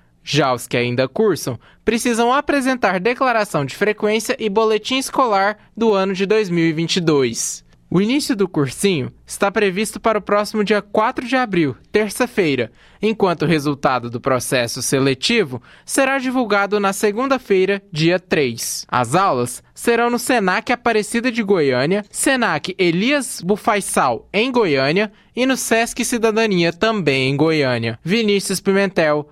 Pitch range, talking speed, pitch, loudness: 155-230 Hz, 135 wpm, 205 Hz, -18 LUFS